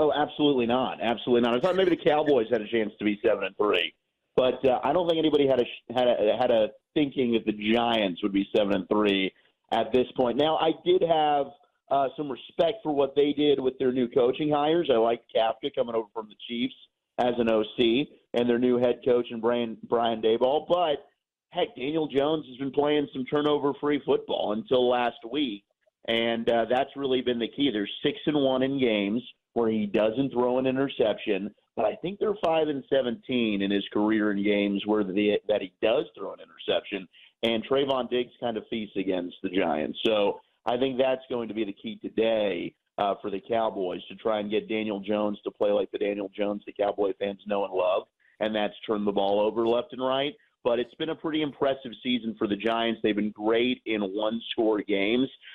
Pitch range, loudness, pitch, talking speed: 110-140 Hz, -27 LUFS, 120 Hz, 215 wpm